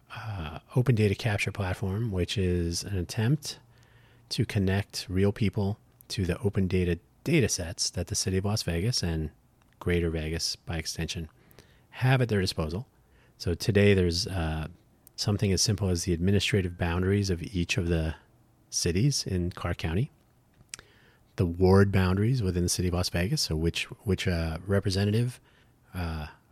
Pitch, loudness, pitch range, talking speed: 100 Hz, -28 LUFS, 90-115 Hz, 155 wpm